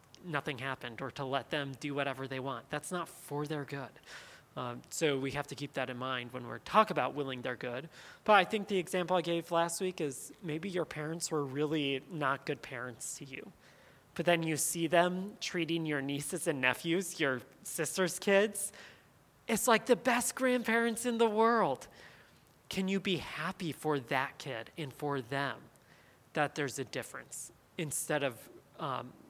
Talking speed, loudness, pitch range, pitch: 180 wpm, -34 LUFS, 135-185 Hz, 150 Hz